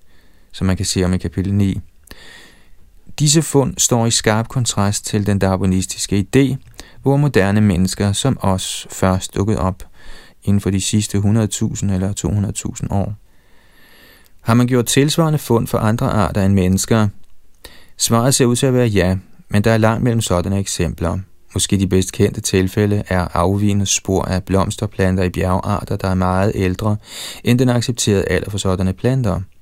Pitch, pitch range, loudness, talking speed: 100 Hz, 95-115 Hz, -17 LUFS, 165 wpm